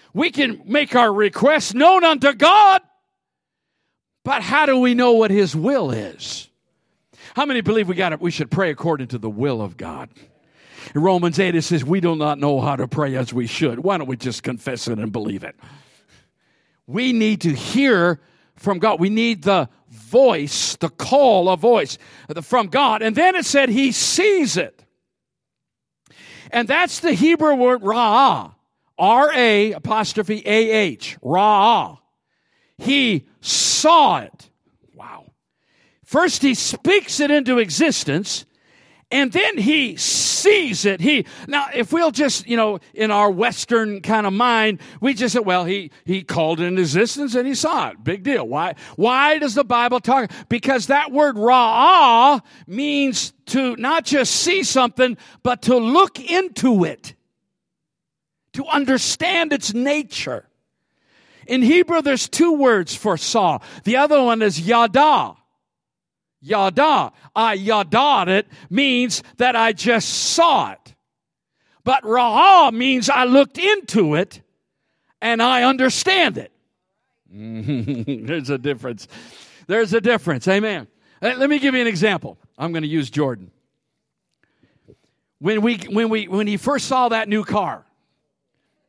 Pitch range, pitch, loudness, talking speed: 175-275 Hz, 230 Hz, -17 LUFS, 150 wpm